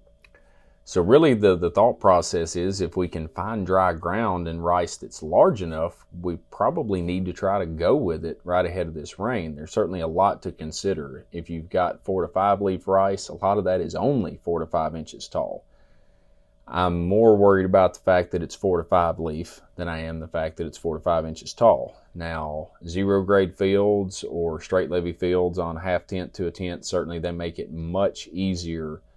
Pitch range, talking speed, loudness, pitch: 80-95 Hz, 210 wpm, -24 LUFS, 90 Hz